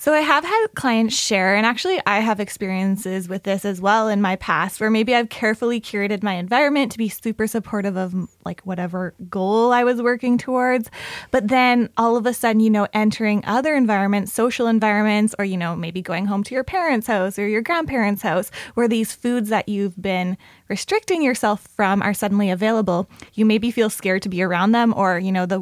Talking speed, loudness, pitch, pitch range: 205 wpm, -20 LUFS, 215 Hz, 195-235 Hz